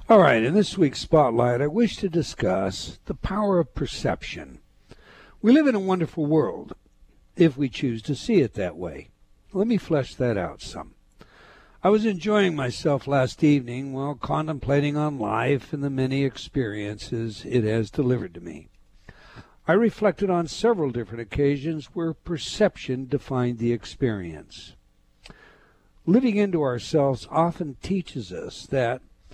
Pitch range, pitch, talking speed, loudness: 125-175 Hz, 145 Hz, 145 wpm, -24 LUFS